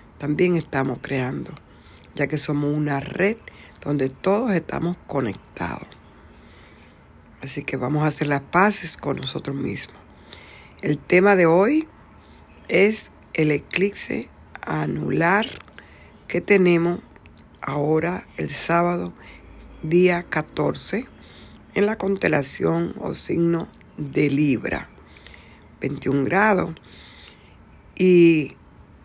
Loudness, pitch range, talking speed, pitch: -21 LUFS, 105-175 Hz, 95 wpm, 145 Hz